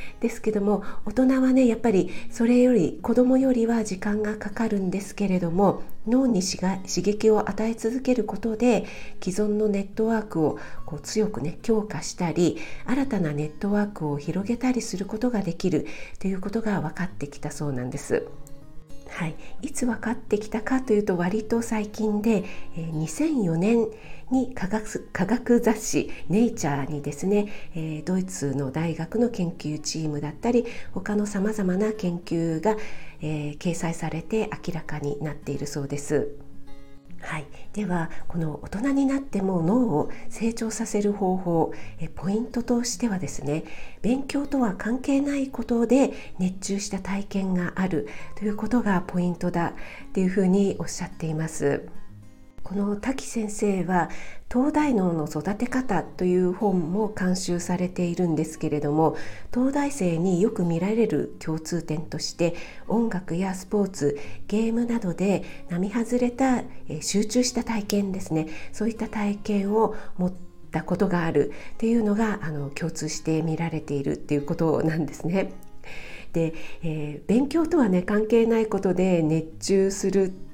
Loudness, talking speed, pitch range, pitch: -26 LUFS, 290 characters per minute, 160-225 Hz, 195 Hz